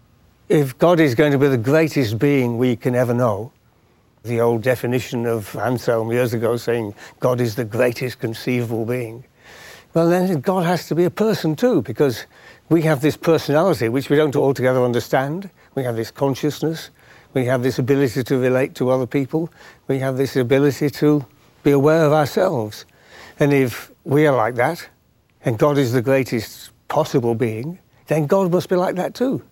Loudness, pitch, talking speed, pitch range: -19 LUFS, 135 Hz, 180 wpm, 125-155 Hz